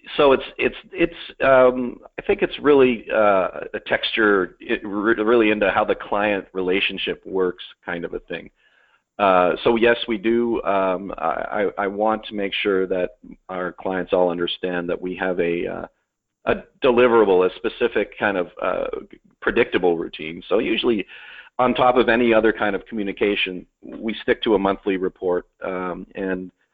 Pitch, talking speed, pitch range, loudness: 105 Hz, 165 wpm, 95-125 Hz, -21 LUFS